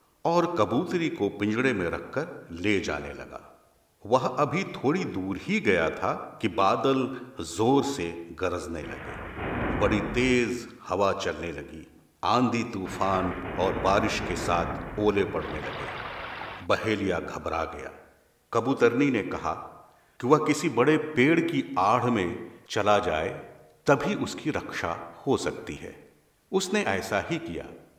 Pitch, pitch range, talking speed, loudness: 105 Hz, 95-130 Hz, 135 wpm, -27 LUFS